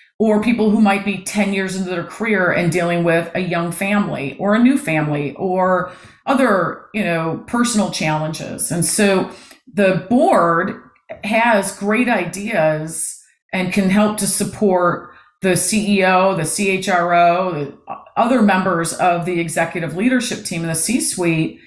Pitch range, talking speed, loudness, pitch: 170-210 Hz, 145 wpm, -17 LUFS, 185 Hz